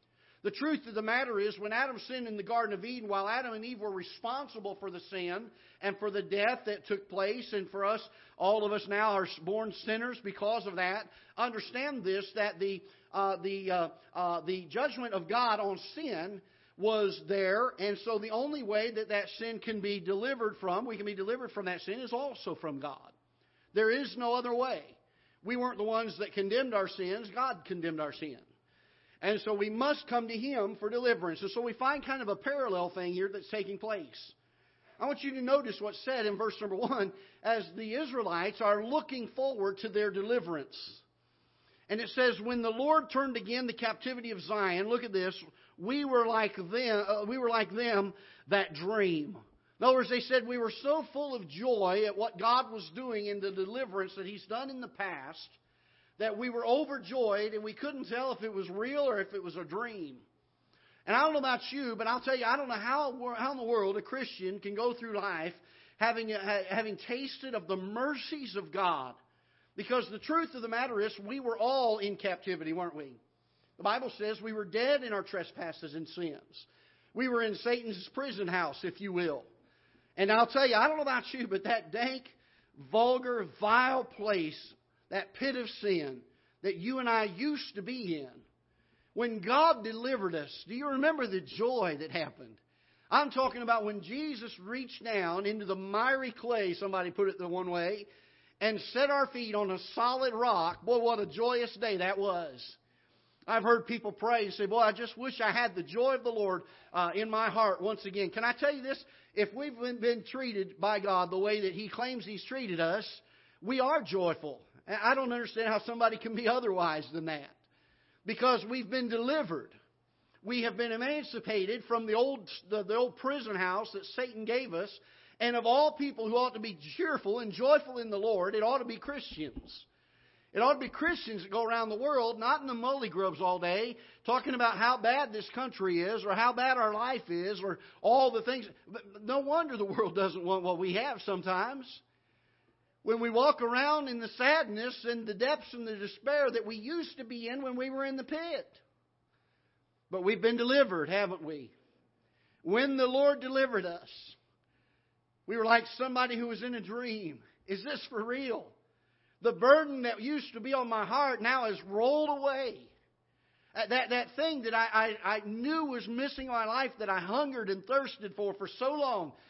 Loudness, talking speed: -33 LUFS, 200 wpm